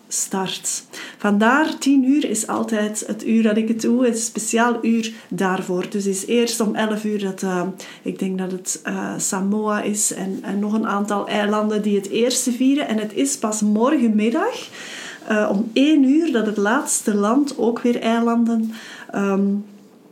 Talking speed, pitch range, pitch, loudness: 180 wpm, 205-235 Hz, 220 Hz, -20 LUFS